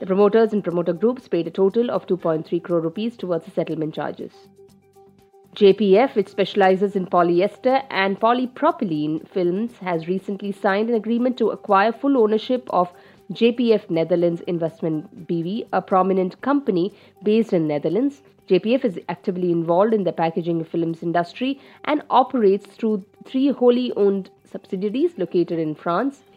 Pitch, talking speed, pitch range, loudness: 195 Hz, 145 wpm, 175-220 Hz, -21 LUFS